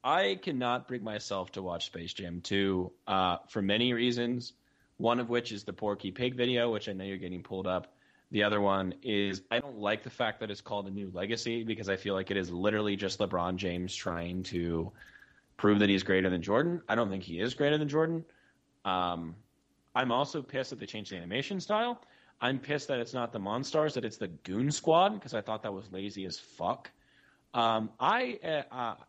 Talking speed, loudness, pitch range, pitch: 210 wpm, -32 LUFS, 95-125 Hz, 105 Hz